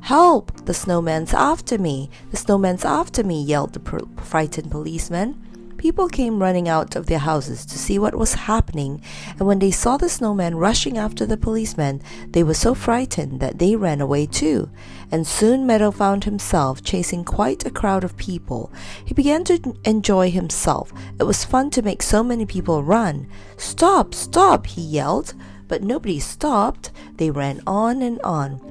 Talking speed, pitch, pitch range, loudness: 170 wpm, 185 Hz, 155-225 Hz, -20 LUFS